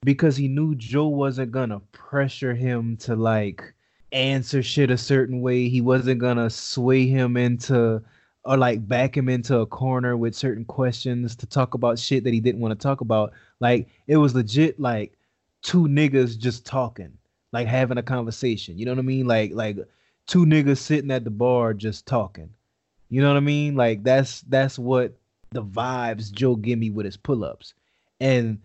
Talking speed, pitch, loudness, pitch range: 180 wpm, 125 Hz, -22 LUFS, 115-130 Hz